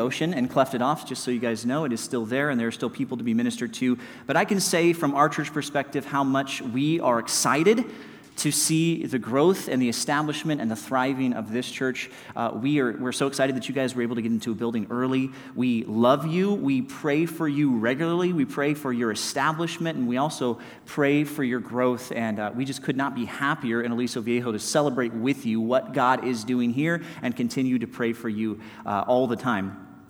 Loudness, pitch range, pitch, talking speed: -25 LUFS, 120-145 Hz, 130 Hz, 230 wpm